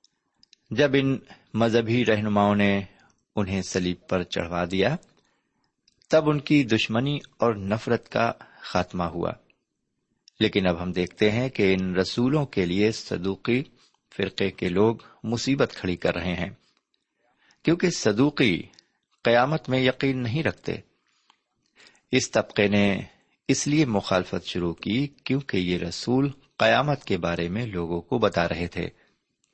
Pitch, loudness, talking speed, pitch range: 110 Hz, -25 LUFS, 130 wpm, 95-130 Hz